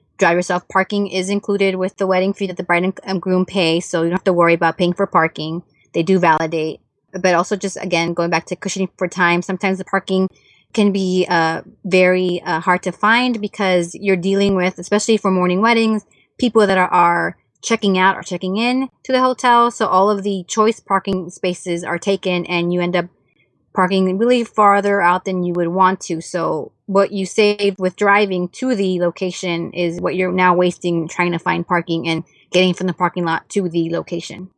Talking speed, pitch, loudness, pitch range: 205 wpm, 185 Hz, -17 LUFS, 175-195 Hz